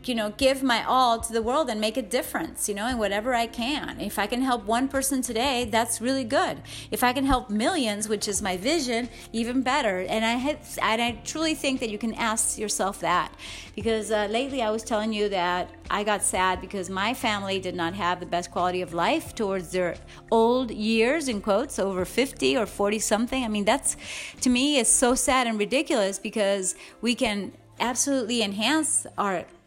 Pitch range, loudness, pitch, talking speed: 205-255 Hz, -25 LUFS, 230 Hz, 205 wpm